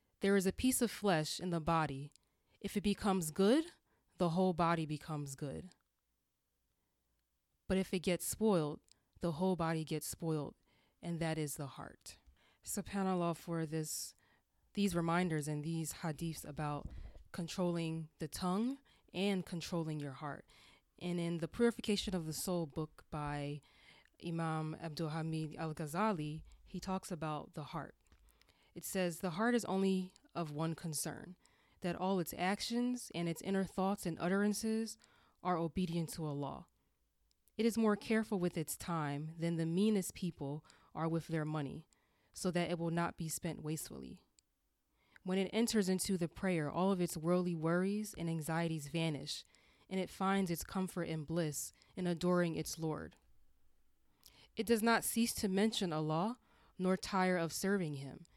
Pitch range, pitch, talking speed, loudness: 155-190 Hz, 170 Hz, 155 wpm, -38 LUFS